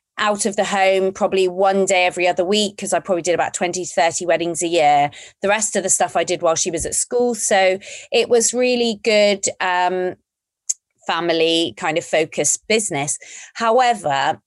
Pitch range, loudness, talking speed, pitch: 170-210 Hz, -18 LUFS, 185 wpm, 190 Hz